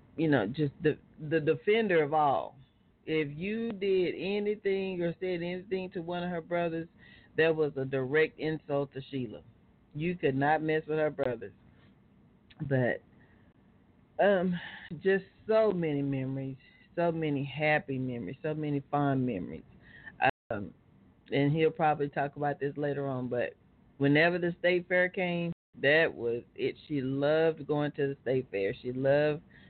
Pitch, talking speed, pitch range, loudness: 155 Hz, 150 wpm, 140-175 Hz, -31 LUFS